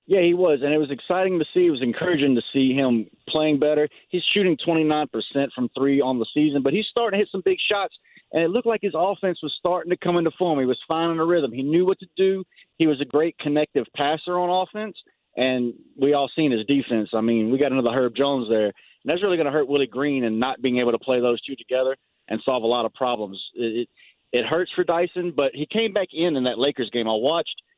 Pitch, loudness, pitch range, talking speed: 145 Hz, -22 LUFS, 125-175 Hz, 255 wpm